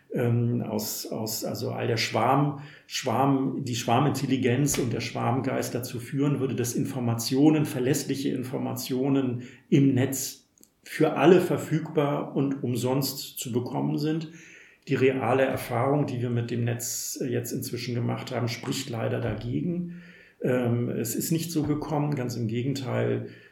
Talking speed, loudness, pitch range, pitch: 135 wpm, -27 LUFS, 120-145 Hz, 130 Hz